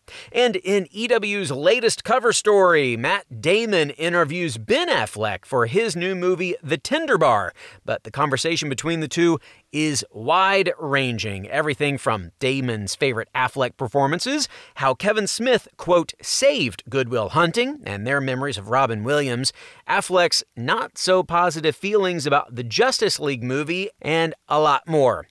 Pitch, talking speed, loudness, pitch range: 155 Hz, 140 wpm, -21 LUFS, 130-185 Hz